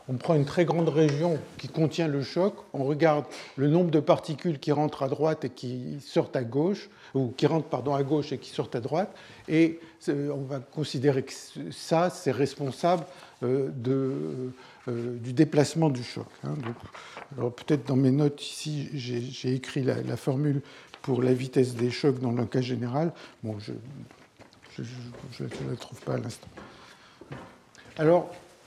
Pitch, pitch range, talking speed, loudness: 145 Hz, 130-160 Hz, 165 wpm, -28 LUFS